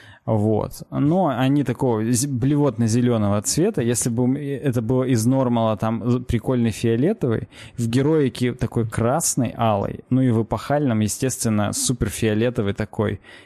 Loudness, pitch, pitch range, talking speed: -21 LUFS, 120 Hz, 110-130 Hz, 125 wpm